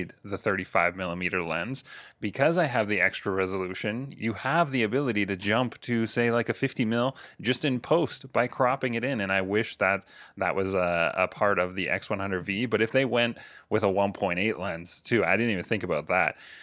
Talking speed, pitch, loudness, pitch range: 200 wpm, 105 Hz, -27 LUFS, 95-120 Hz